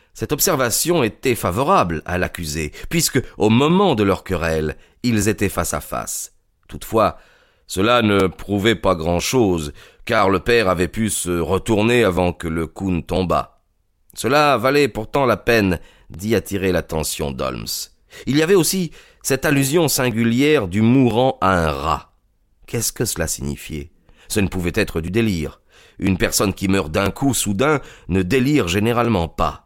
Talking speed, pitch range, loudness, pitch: 160 wpm, 85-120 Hz, -19 LUFS, 100 Hz